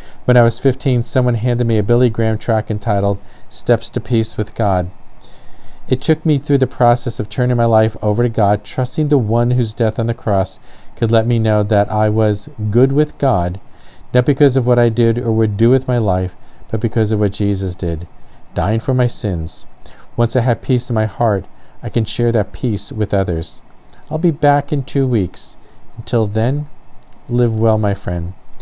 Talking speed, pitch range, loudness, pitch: 200 wpm, 105-125 Hz, -16 LUFS, 115 Hz